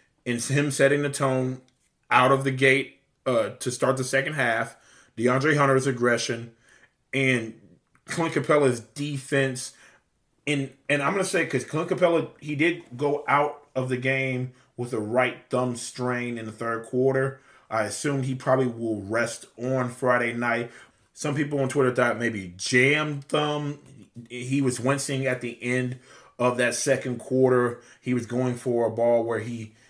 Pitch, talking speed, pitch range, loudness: 130 Hz, 165 wpm, 120-140 Hz, -25 LUFS